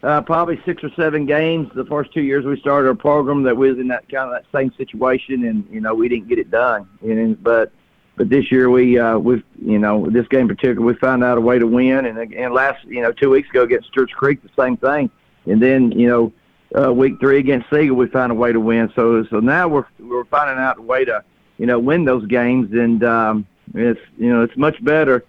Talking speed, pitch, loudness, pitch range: 250 wpm, 130 Hz, -16 LUFS, 120-150 Hz